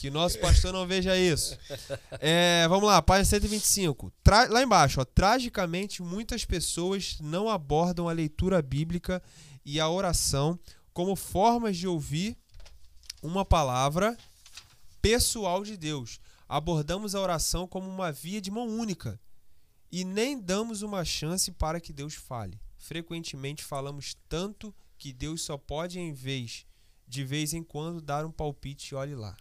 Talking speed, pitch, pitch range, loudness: 145 wpm, 165 Hz, 140-190 Hz, -28 LUFS